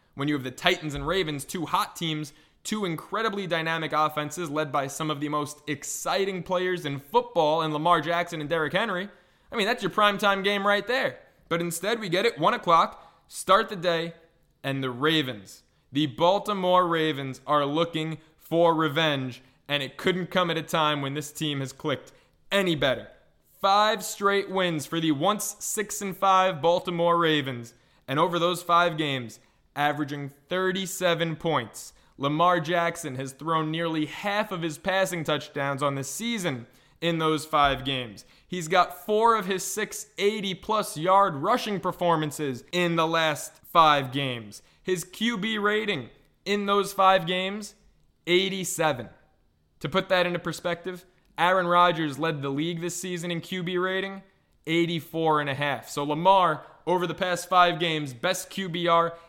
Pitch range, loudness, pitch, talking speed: 150-185 Hz, -26 LUFS, 170 Hz, 160 wpm